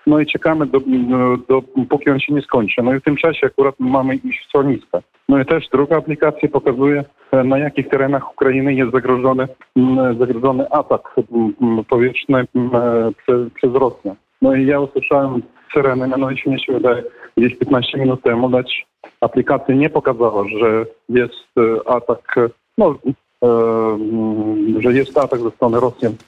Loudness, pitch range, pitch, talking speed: -16 LUFS, 120-140 Hz, 130 Hz, 150 wpm